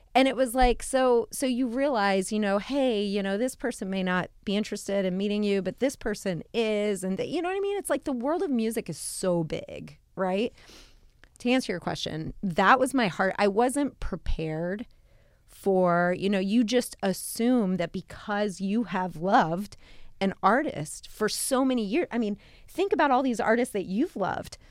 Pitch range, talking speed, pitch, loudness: 190-255 Hz, 195 wpm, 210 Hz, -27 LUFS